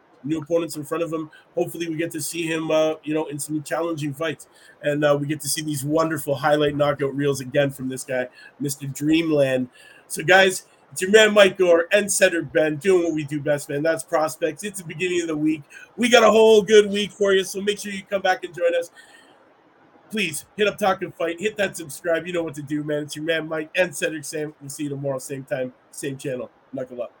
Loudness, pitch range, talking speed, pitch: -22 LUFS, 150-185 Hz, 240 wpm, 160 Hz